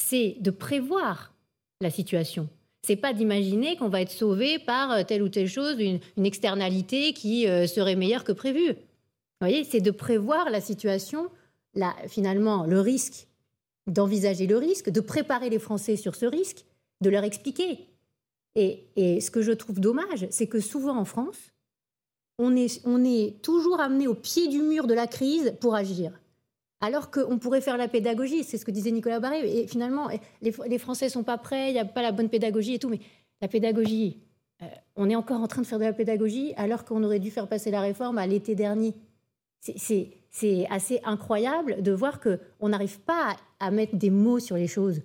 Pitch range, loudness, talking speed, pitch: 200-250 Hz, -27 LUFS, 195 wpm, 220 Hz